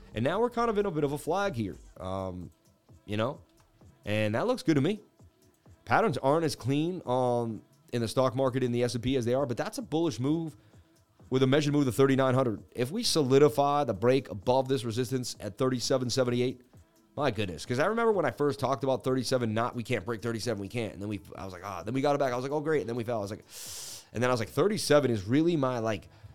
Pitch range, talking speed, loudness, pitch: 115-145 Hz, 255 wpm, -29 LUFS, 125 Hz